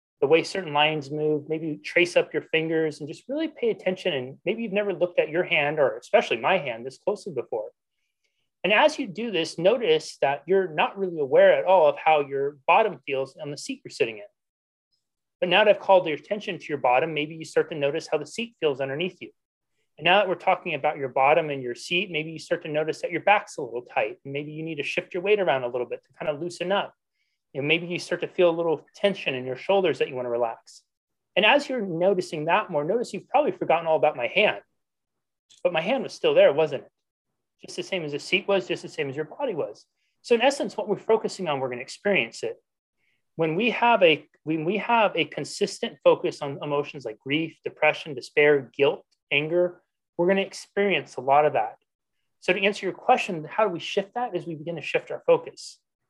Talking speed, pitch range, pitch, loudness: 235 wpm, 150-210 Hz, 175 Hz, -24 LUFS